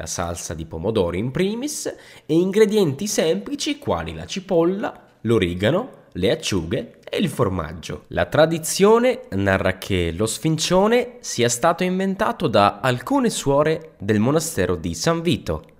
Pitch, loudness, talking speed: 160 Hz, -21 LUFS, 135 wpm